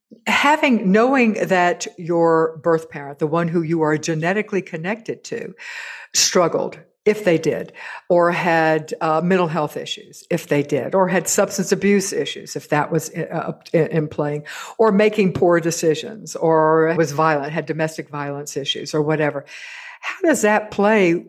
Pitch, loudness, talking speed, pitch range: 170 Hz, -19 LUFS, 160 wpm, 155-200 Hz